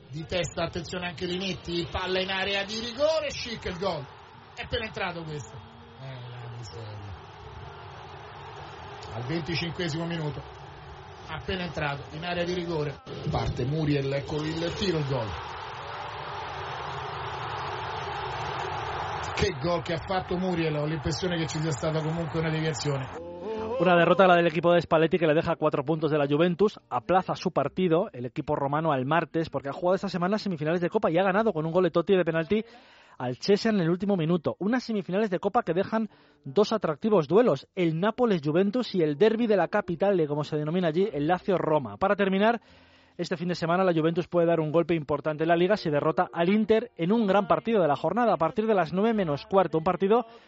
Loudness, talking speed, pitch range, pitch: -27 LUFS, 190 wpm, 155-190 Hz, 170 Hz